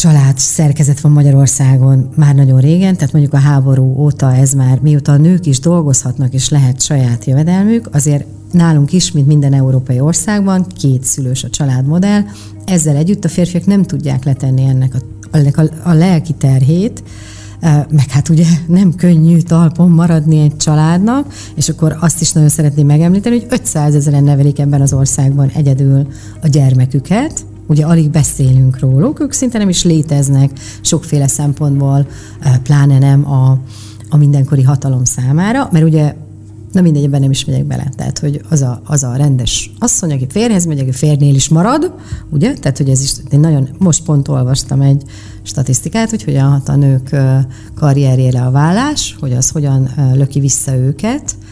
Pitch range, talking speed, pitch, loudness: 135-160 Hz, 165 wpm, 145 Hz, -11 LUFS